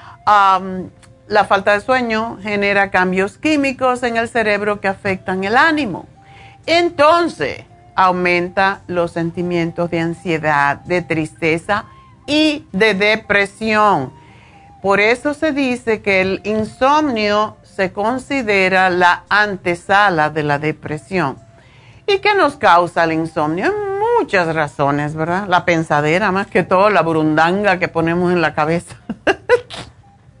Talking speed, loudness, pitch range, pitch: 120 wpm, -16 LUFS, 165-220 Hz, 190 Hz